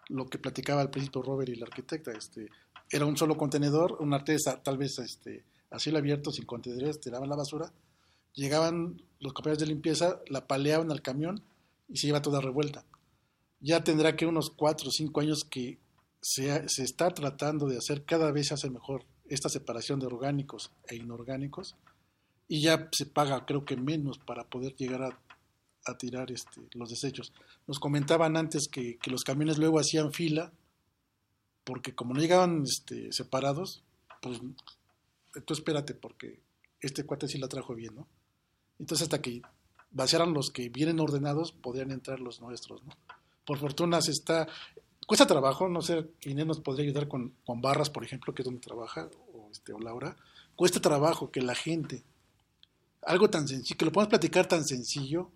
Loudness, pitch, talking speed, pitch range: -31 LUFS, 145 Hz, 175 wpm, 130-155 Hz